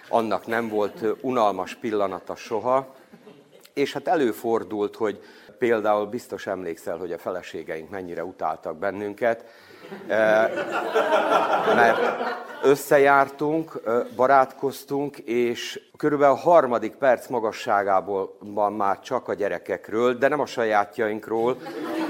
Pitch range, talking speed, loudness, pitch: 105-135 Hz, 100 wpm, -24 LUFS, 115 Hz